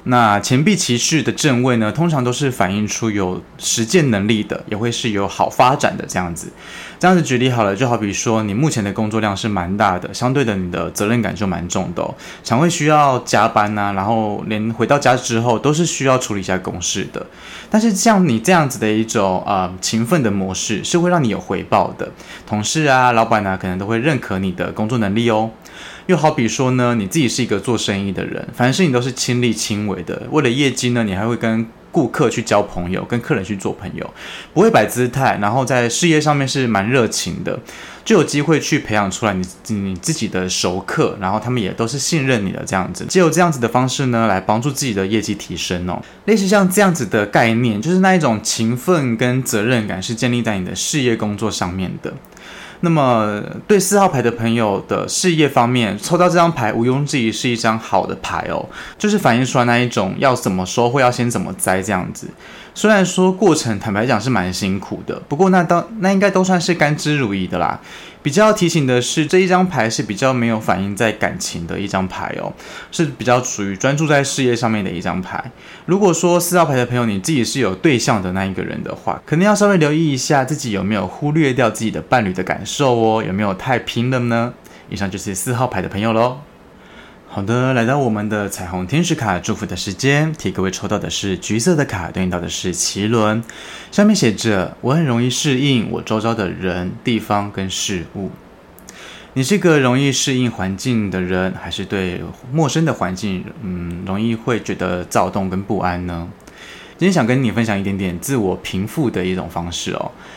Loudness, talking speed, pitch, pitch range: -17 LUFS, 315 characters per minute, 115 Hz, 100-140 Hz